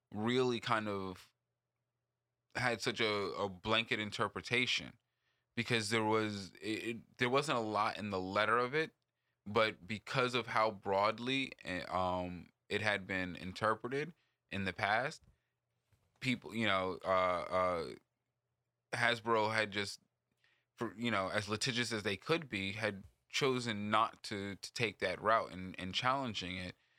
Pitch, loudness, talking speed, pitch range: 110 Hz, -36 LUFS, 145 wpm, 100-120 Hz